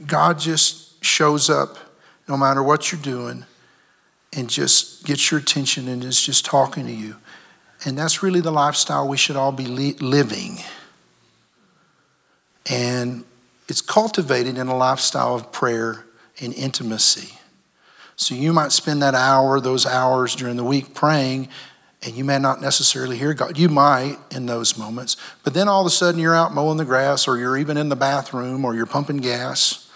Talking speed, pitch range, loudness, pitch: 170 wpm, 125-150 Hz, -18 LUFS, 135 Hz